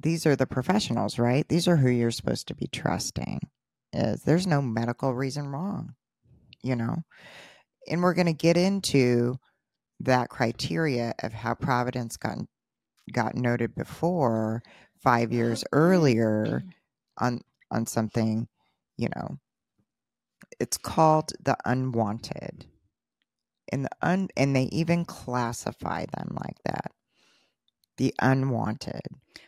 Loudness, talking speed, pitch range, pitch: -27 LUFS, 120 wpm, 115-160 Hz, 130 Hz